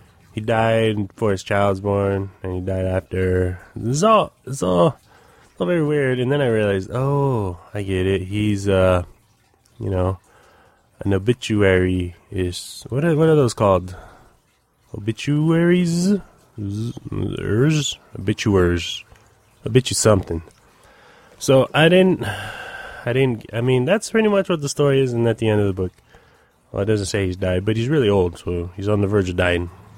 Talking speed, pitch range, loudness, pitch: 170 wpm, 95-130 Hz, -20 LUFS, 105 Hz